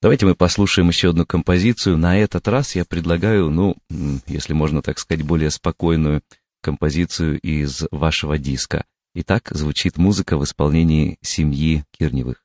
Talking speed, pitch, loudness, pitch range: 140 wpm, 80 Hz, -19 LUFS, 75-90 Hz